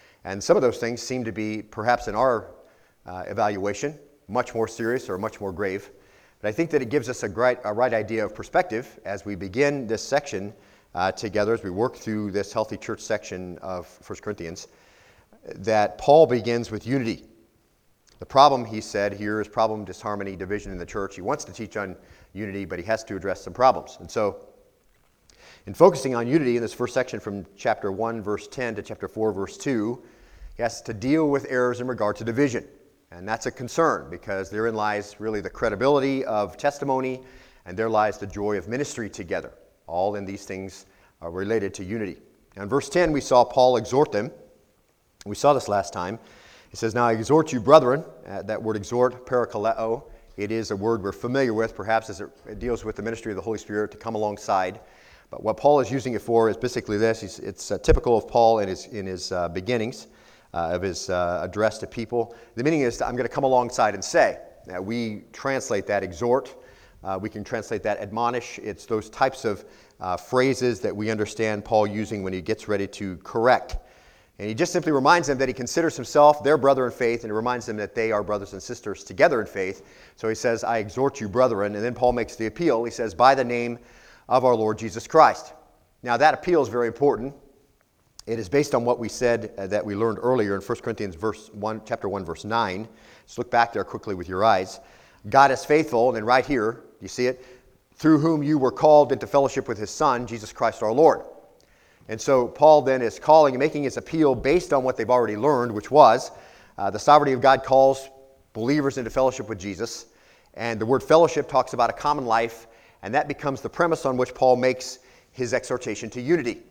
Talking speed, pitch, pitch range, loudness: 215 wpm, 115 Hz, 105-130 Hz, -23 LUFS